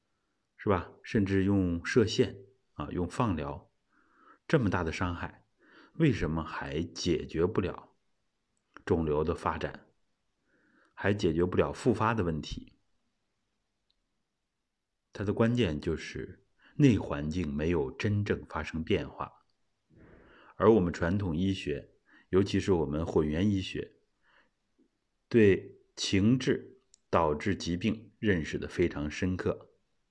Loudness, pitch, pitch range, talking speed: -30 LUFS, 95 Hz, 80-110 Hz, 175 characters per minute